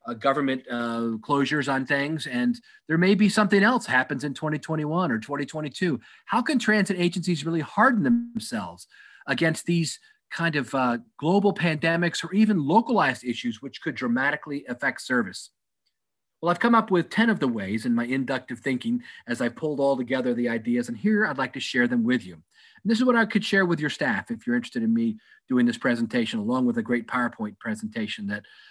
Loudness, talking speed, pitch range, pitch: -25 LUFS, 195 wpm, 135-225 Hz, 170 Hz